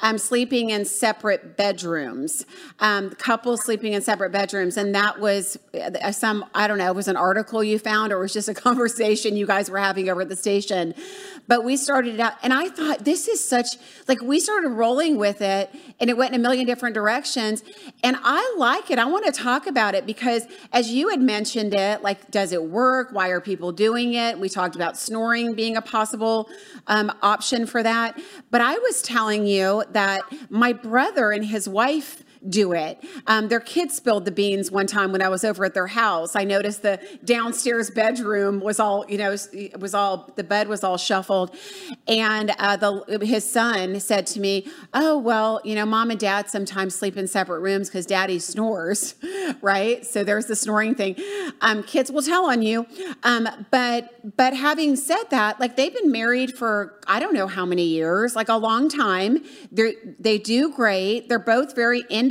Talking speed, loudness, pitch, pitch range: 200 wpm, -22 LUFS, 220 Hz, 200-250 Hz